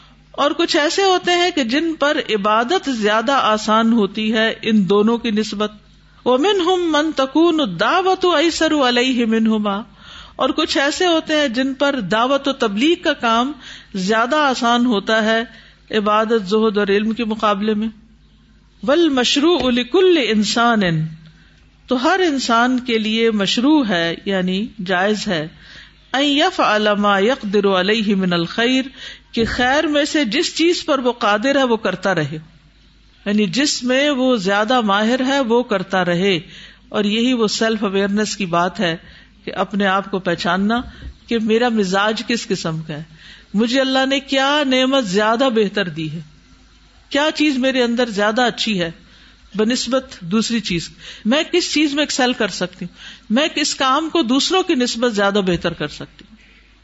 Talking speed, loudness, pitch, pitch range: 160 wpm, -17 LUFS, 230 Hz, 205-275 Hz